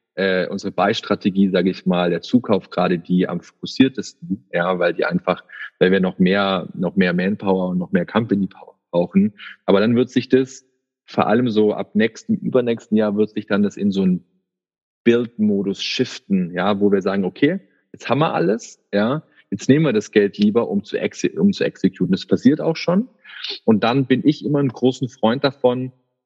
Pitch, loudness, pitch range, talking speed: 110 Hz, -19 LUFS, 95-140 Hz, 190 wpm